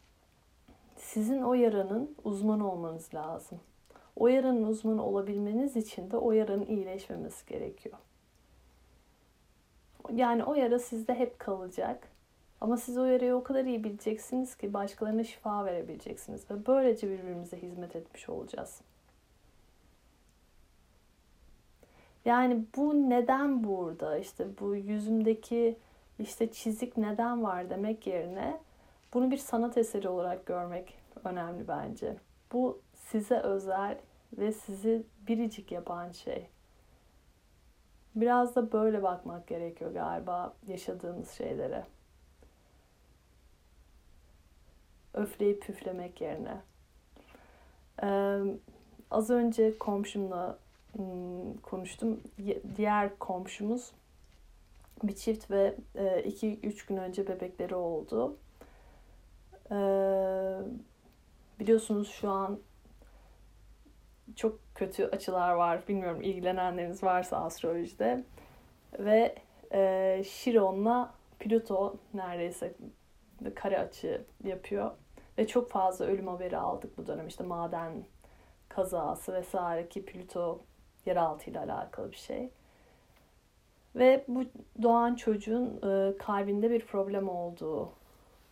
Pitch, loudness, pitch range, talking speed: 200 Hz, -33 LUFS, 180-230 Hz, 100 wpm